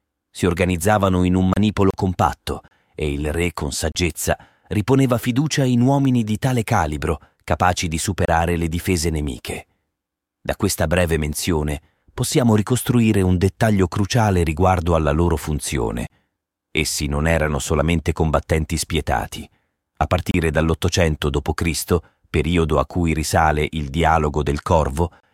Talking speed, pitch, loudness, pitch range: 130 wpm, 85 Hz, -20 LUFS, 80-100 Hz